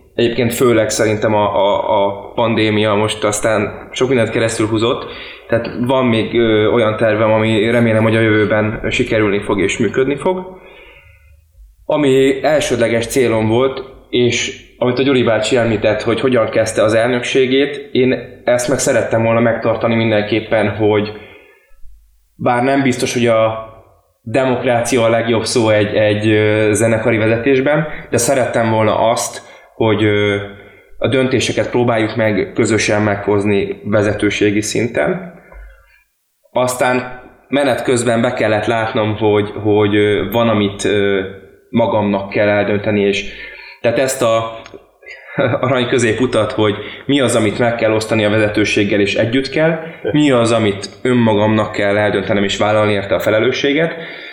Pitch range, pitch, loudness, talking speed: 105-120 Hz, 110 Hz, -15 LUFS, 135 wpm